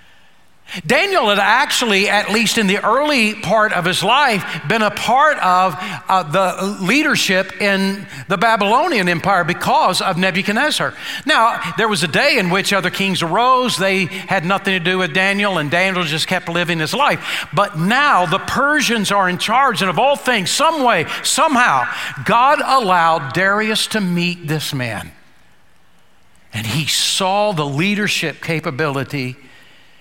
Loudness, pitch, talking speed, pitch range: -15 LUFS, 195 Hz, 155 wpm, 175-215 Hz